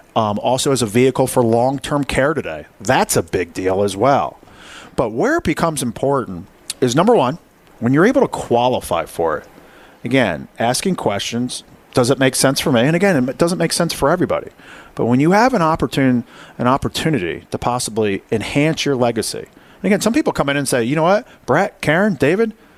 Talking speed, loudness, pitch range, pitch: 195 wpm, -17 LUFS, 125-165 Hz, 140 Hz